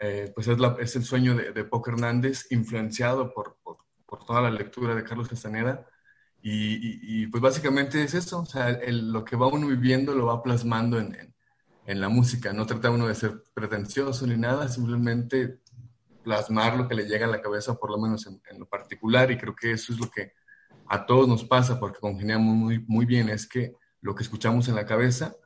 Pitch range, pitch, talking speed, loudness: 110-125 Hz, 120 Hz, 220 wpm, -26 LUFS